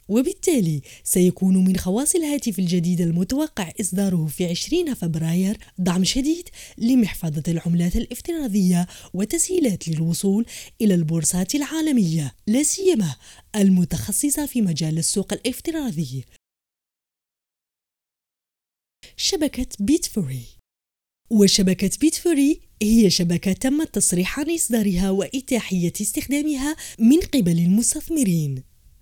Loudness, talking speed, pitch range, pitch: -21 LUFS, 90 wpm, 175-275 Hz, 200 Hz